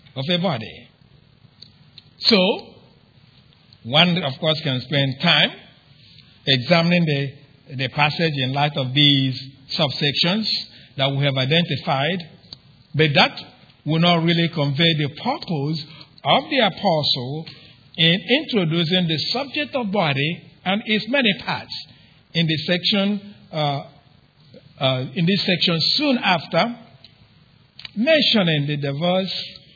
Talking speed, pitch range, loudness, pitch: 115 wpm, 140-180 Hz, -19 LUFS, 155 Hz